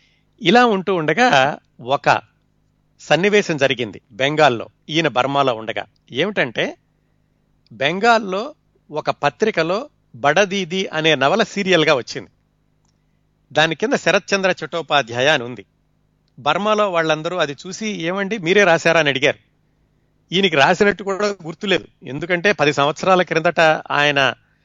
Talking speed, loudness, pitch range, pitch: 105 wpm, -17 LUFS, 145-195 Hz, 165 Hz